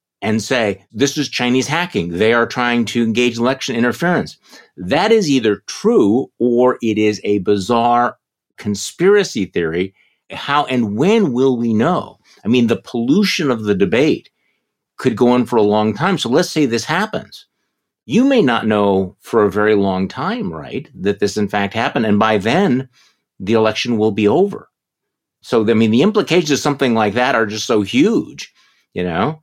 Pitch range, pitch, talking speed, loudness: 105-140 Hz, 120 Hz, 180 wpm, -16 LUFS